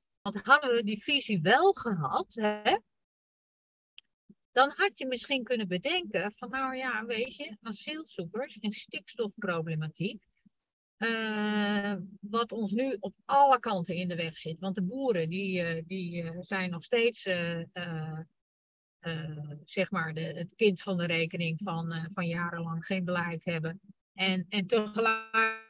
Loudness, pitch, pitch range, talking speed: -31 LUFS, 195 Hz, 170-225 Hz, 145 wpm